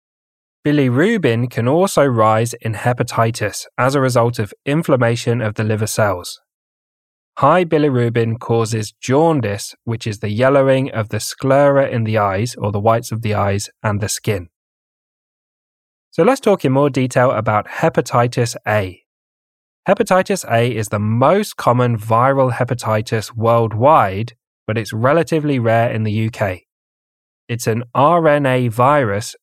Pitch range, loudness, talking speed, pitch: 110-135 Hz, -16 LUFS, 135 wpm, 115 Hz